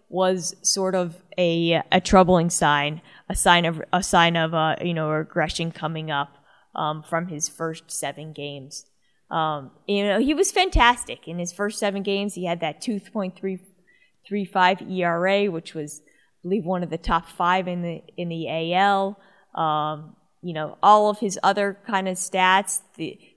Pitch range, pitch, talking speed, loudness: 160-195 Hz, 175 Hz, 180 wpm, -22 LUFS